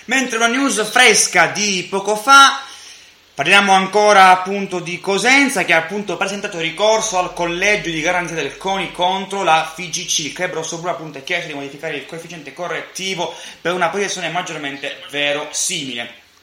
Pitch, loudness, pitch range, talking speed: 180 Hz, -15 LUFS, 165-200 Hz, 155 wpm